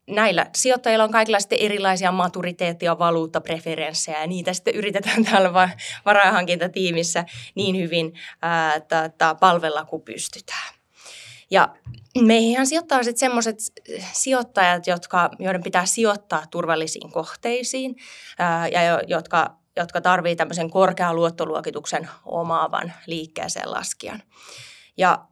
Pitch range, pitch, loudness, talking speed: 165-205 Hz, 180 Hz, -21 LUFS, 100 wpm